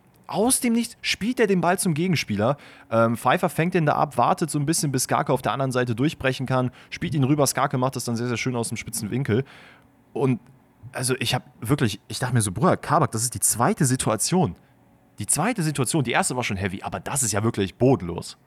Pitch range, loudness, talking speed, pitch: 115-155 Hz, -23 LUFS, 230 wpm, 130 Hz